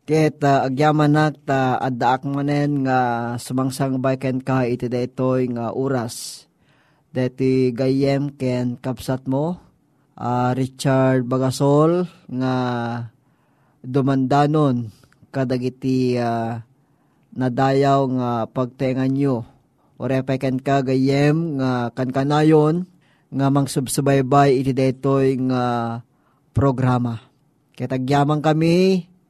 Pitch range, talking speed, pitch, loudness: 125-145 Hz, 100 wpm, 130 Hz, -20 LUFS